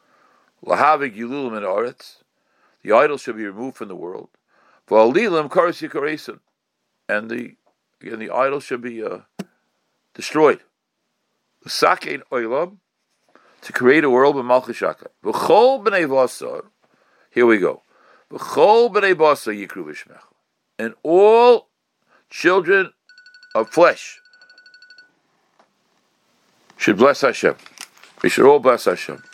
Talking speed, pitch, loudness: 115 wpm, 225 Hz, -17 LUFS